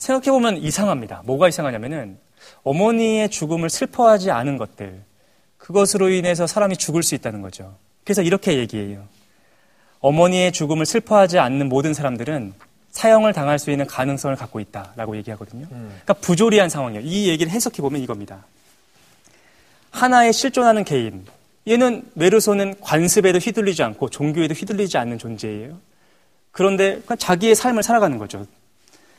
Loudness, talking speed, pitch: -18 LUFS, 380 characters per minute, 160 Hz